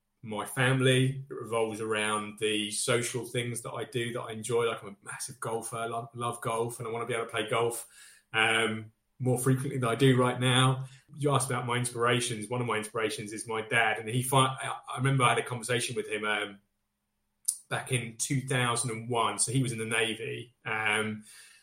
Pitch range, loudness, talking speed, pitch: 110-125 Hz, -30 LUFS, 205 wpm, 115 Hz